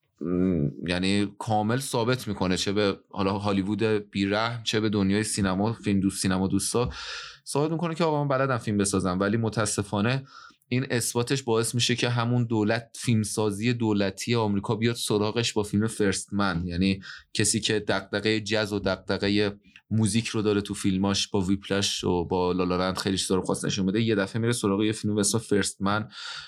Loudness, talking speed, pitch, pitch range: -26 LUFS, 170 wpm, 105 Hz, 100-115 Hz